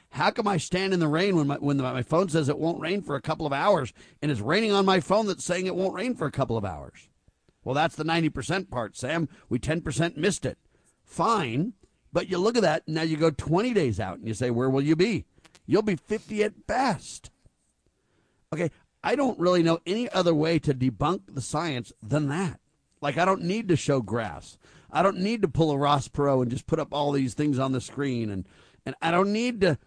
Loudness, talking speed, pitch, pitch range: -26 LUFS, 235 wpm, 155 Hz, 135-185 Hz